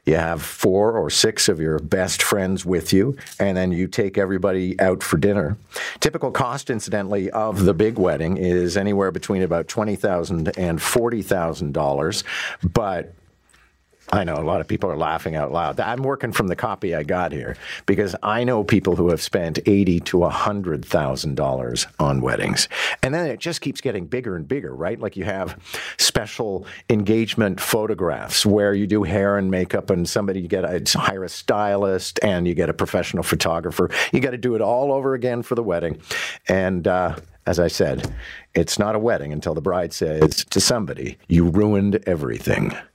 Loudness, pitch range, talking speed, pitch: -21 LUFS, 85-105 Hz, 185 wpm, 95 Hz